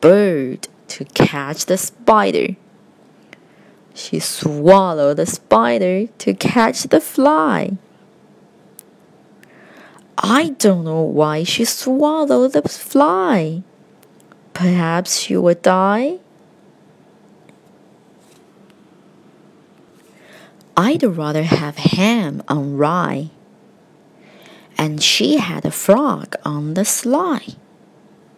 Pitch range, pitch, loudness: 160-230 Hz, 195 Hz, -16 LUFS